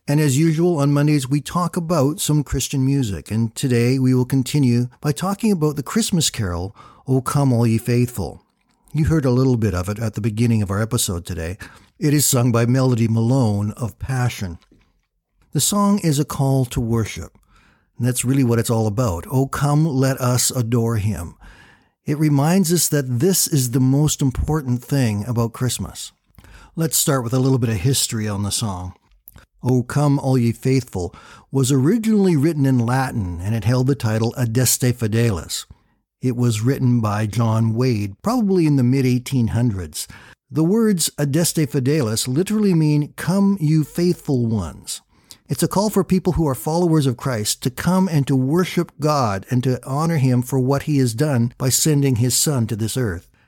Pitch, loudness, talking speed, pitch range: 130 Hz, -19 LUFS, 180 wpm, 115-150 Hz